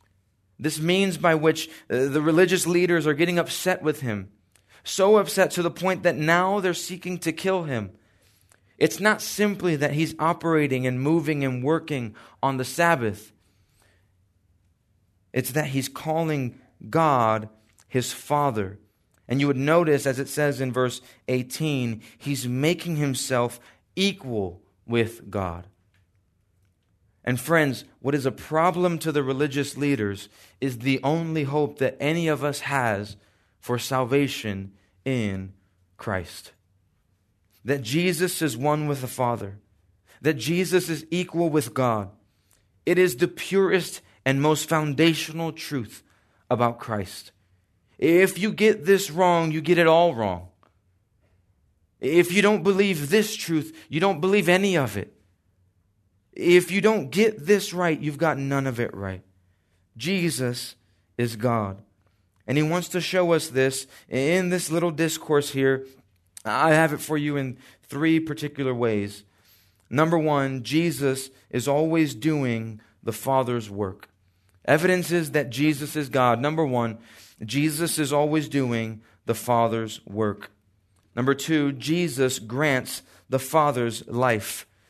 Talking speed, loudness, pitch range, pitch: 140 wpm, -24 LUFS, 105-160 Hz, 135 Hz